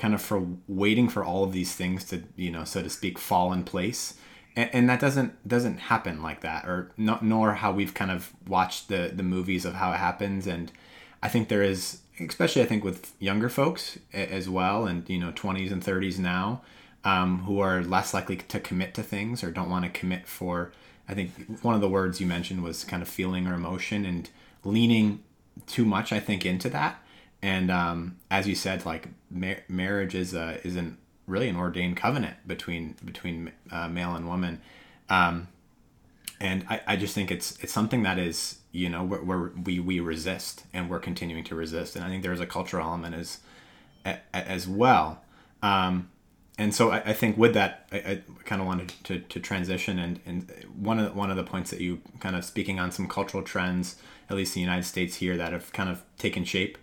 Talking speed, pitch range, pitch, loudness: 210 wpm, 90-100 Hz, 95 Hz, -29 LUFS